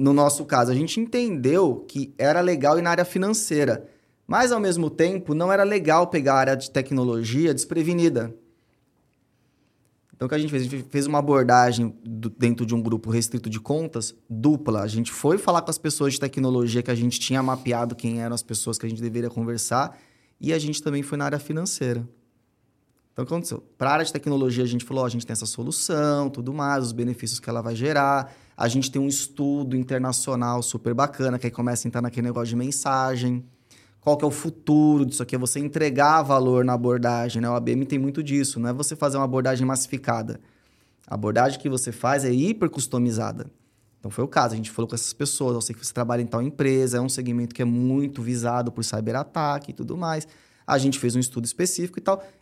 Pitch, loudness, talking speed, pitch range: 130 Hz, -24 LUFS, 220 wpm, 120-145 Hz